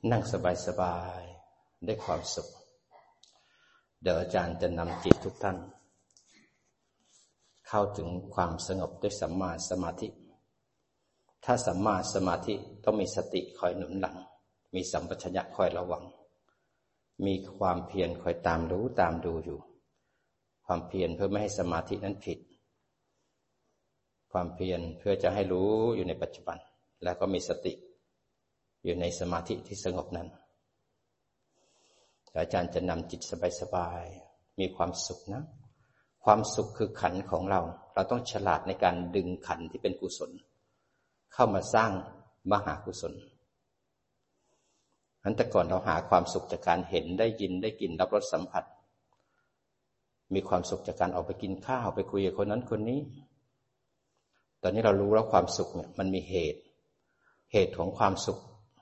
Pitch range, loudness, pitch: 90-110 Hz, -32 LUFS, 95 Hz